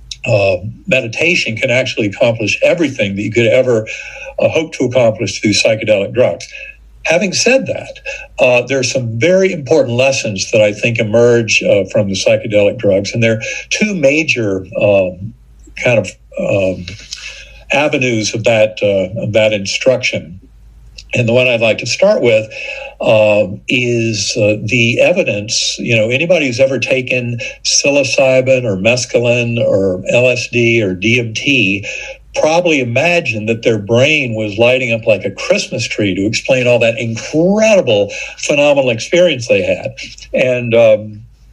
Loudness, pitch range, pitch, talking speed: -12 LUFS, 110-150 Hz, 120 Hz, 145 wpm